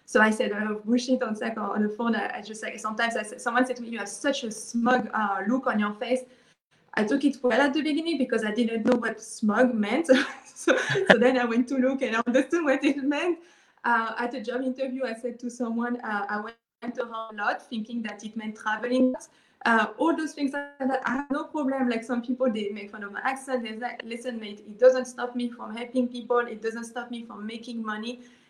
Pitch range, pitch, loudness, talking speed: 225-255 Hz, 245 Hz, -27 LUFS, 255 wpm